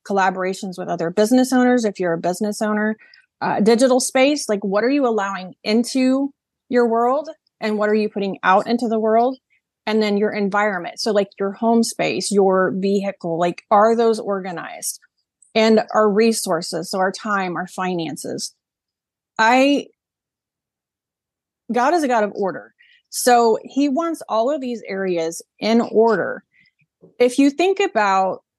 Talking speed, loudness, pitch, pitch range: 155 wpm, -19 LUFS, 215 Hz, 195-245 Hz